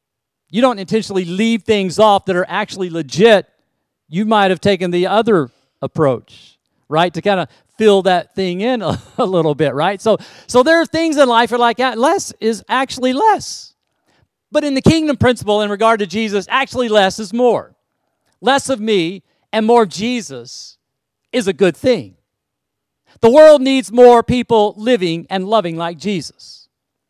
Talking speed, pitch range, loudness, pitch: 170 wpm, 180-240 Hz, -14 LUFS, 210 Hz